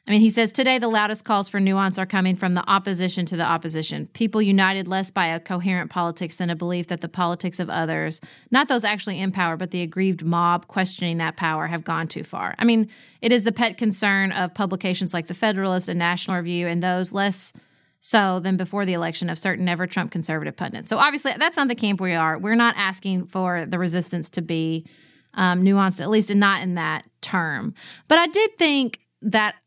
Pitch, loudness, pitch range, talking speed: 185 Hz, -22 LUFS, 175-210 Hz, 215 wpm